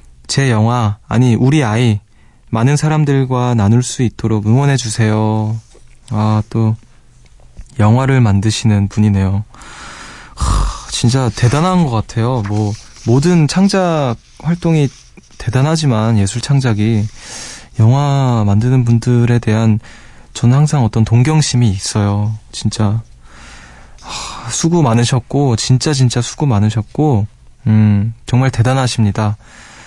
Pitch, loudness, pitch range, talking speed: 115 Hz, -14 LUFS, 110-130 Hz, 240 characters per minute